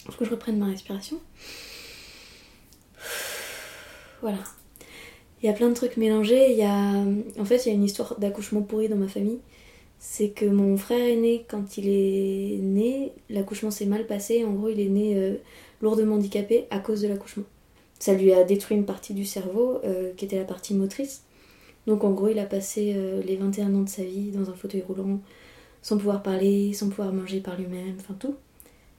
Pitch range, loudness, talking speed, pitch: 195-220 Hz, -26 LUFS, 200 wpm, 205 Hz